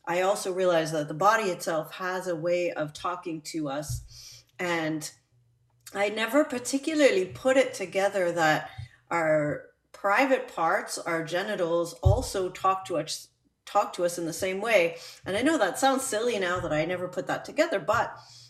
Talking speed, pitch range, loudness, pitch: 170 wpm, 160-210 Hz, -27 LUFS, 180 Hz